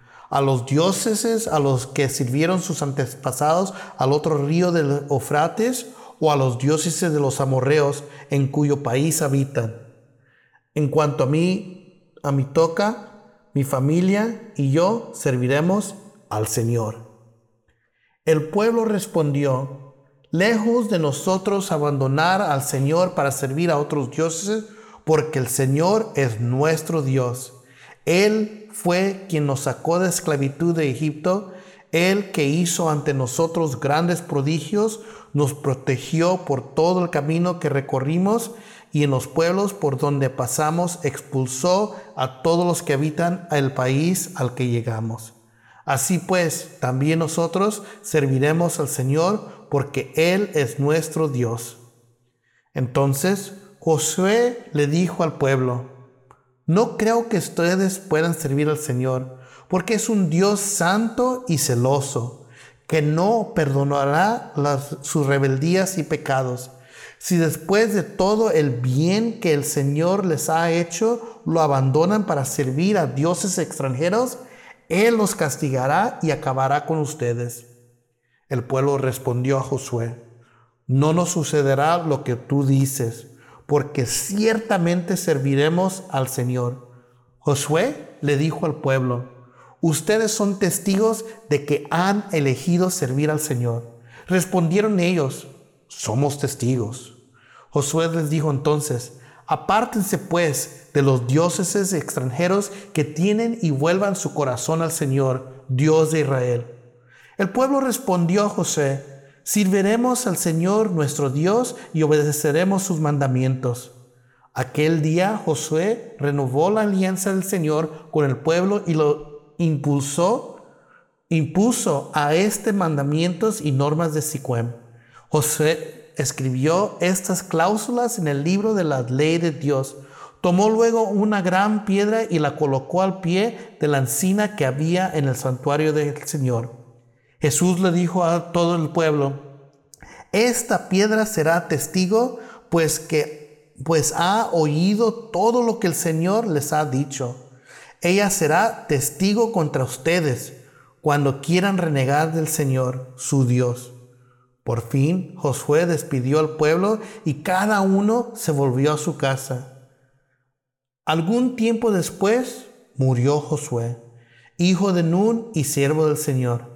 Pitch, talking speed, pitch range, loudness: 155 Hz, 130 wpm, 135-185 Hz, -21 LUFS